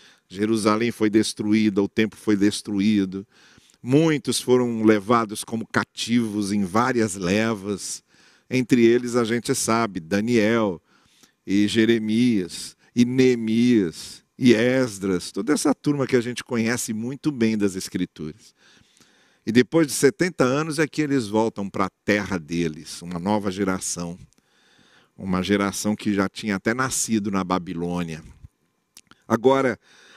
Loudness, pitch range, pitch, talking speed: -22 LUFS, 100-120 Hz, 110 Hz, 125 wpm